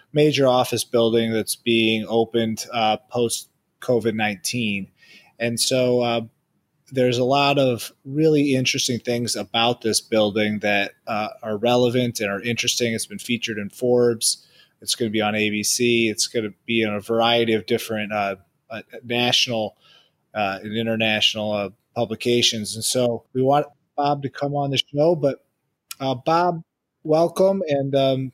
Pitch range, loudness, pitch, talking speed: 110-130 Hz, -21 LUFS, 120 Hz, 155 wpm